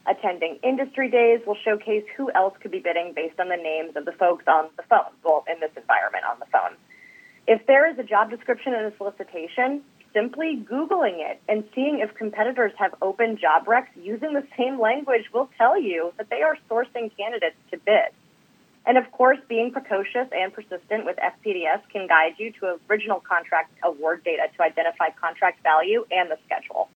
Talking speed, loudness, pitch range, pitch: 190 wpm, -23 LUFS, 175-250 Hz, 215 Hz